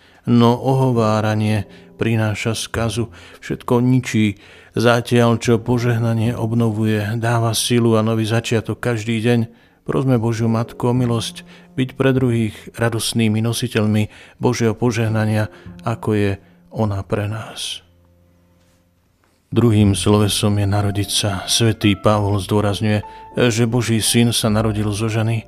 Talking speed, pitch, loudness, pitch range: 115 wpm, 110 Hz, -18 LUFS, 105-120 Hz